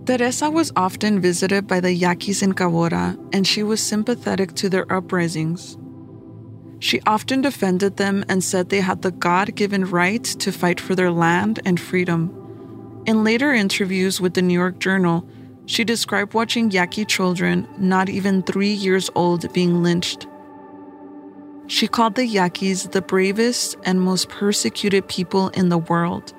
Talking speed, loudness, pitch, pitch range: 150 wpm, -19 LUFS, 190 Hz, 175-205 Hz